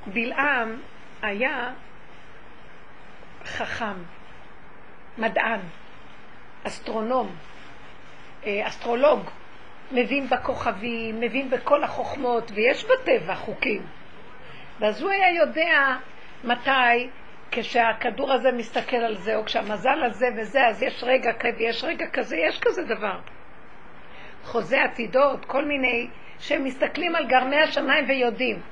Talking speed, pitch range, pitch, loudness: 100 wpm, 235-275 Hz, 250 Hz, -24 LUFS